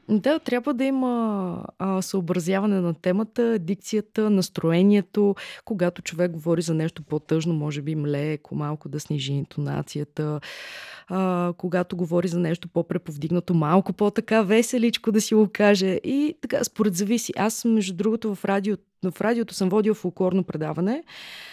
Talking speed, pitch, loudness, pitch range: 140 wpm, 190 Hz, -24 LUFS, 170-220 Hz